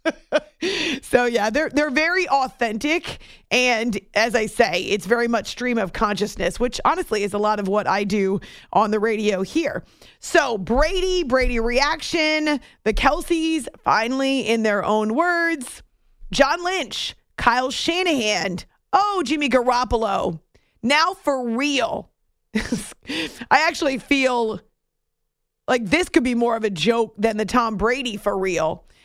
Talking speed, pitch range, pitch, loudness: 140 wpm, 215-305 Hz, 245 Hz, -21 LUFS